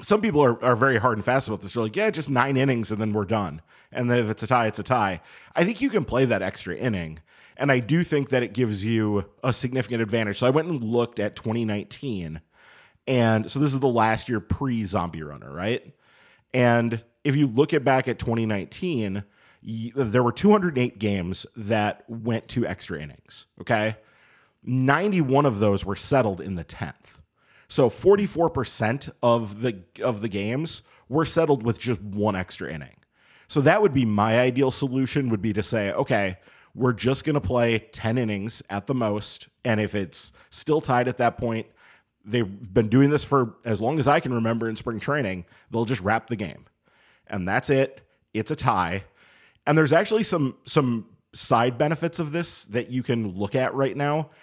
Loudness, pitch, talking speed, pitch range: -24 LUFS, 120 Hz, 195 wpm, 110-135 Hz